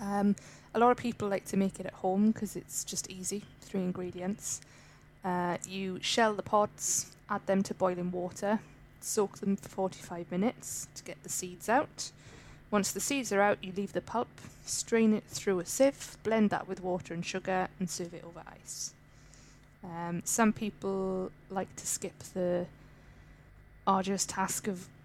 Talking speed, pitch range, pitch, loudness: 175 wpm, 175-205 Hz, 190 Hz, -33 LUFS